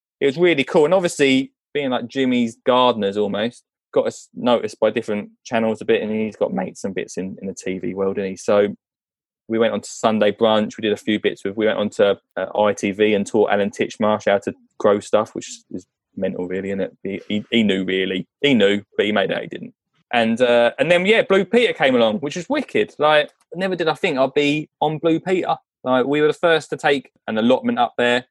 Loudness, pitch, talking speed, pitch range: -19 LUFS, 120 Hz, 235 wpm, 105-150 Hz